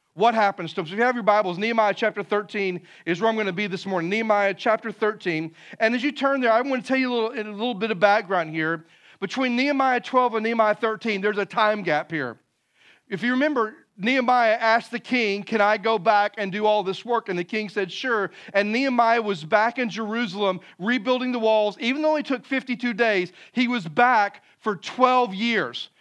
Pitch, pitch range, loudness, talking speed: 220 Hz, 200-245 Hz, -23 LUFS, 220 wpm